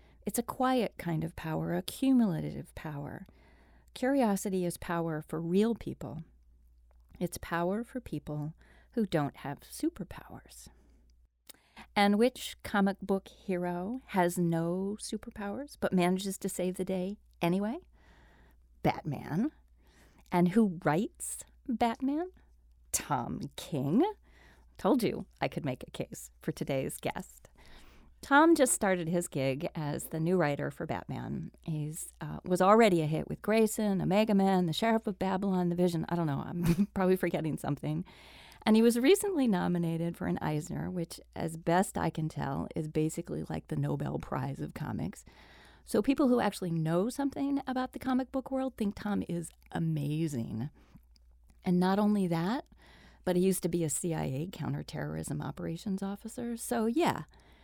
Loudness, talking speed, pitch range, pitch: -32 LUFS, 150 wpm, 155-215 Hz, 180 Hz